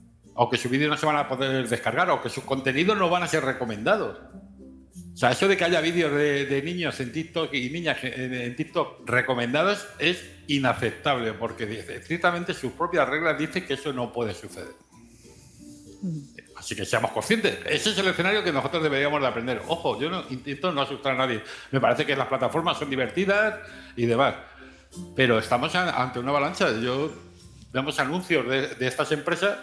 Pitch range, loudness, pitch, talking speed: 120-165 Hz, -25 LUFS, 135 Hz, 185 wpm